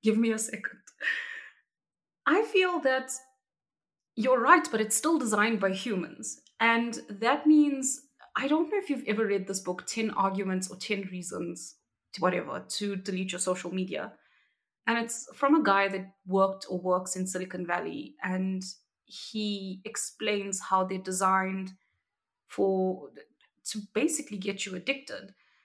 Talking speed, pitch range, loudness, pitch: 145 wpm, 190-260 Hz, -29 LUFS, 205 Hz